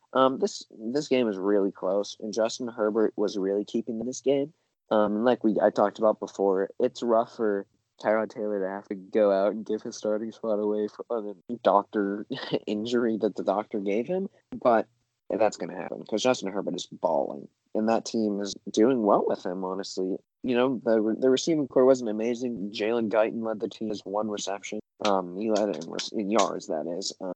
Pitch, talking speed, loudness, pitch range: 110 Hz, 205 wpm, -27 LUFS, 100-120 Hz